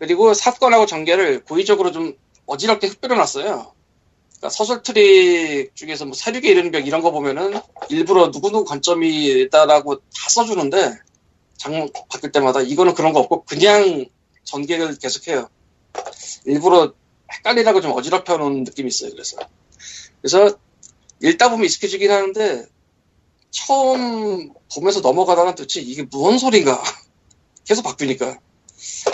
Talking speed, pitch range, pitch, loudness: 325 characters per minute, 155-250 Hz, 200 Hz, -17 LUFS